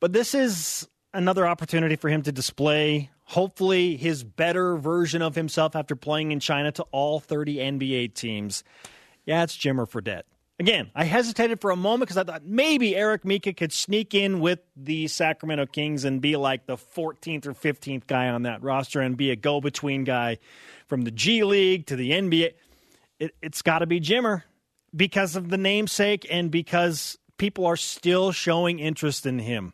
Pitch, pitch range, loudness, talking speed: 160 Hz, 140-185 Hz, -25 LUFS, 180 wpm